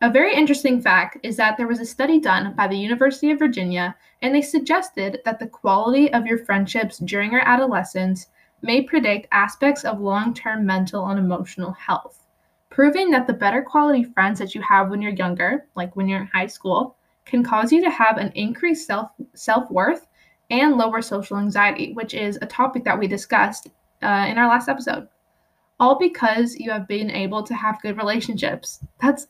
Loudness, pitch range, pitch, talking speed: -20 LUFS, 200-265 Hz, 225 Hz, 185 wpm